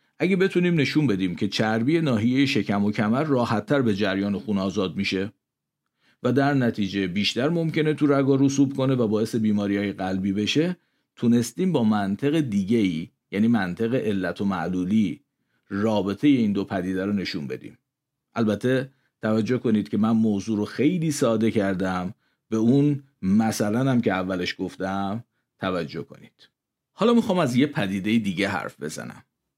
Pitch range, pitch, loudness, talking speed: 100-140 Hz, 110 Hz, -23 LUFS, 155 wpm